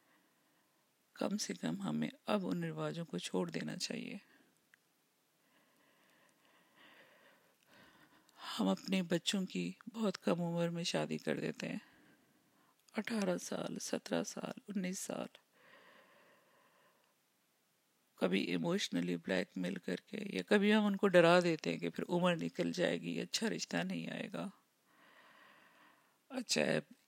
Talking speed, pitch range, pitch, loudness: 70 wpm, 165-210 Hz, 185 Hz, -37 LUFS